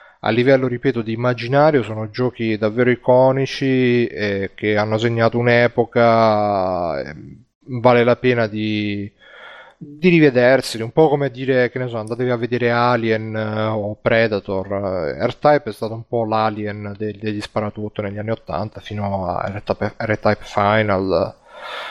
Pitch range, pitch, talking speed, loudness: 105-125 Hz, 115 Hz, 140 wpm, -18 LUFS